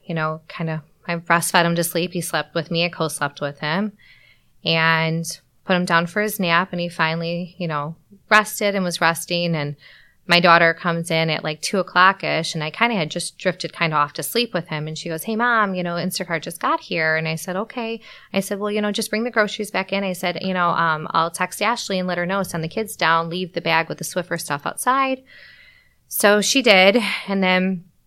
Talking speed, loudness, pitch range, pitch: 240 wpm, -20 LUFS, 165-200 Hz, 175 Hz